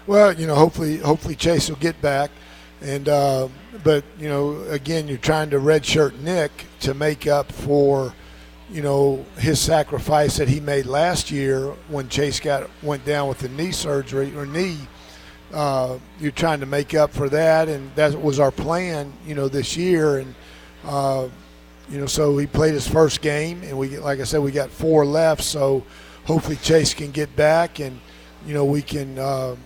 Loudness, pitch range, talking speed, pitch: -21 LUFS, 135-155 Hz, 185 wpm, 145 Hz